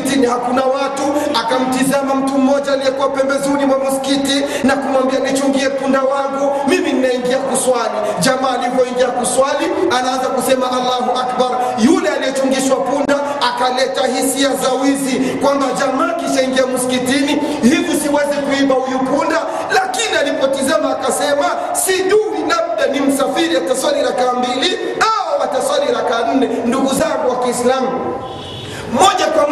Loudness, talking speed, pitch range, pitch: -15 LUFS, 110 wpm, 255-285 Hz, 270 Hz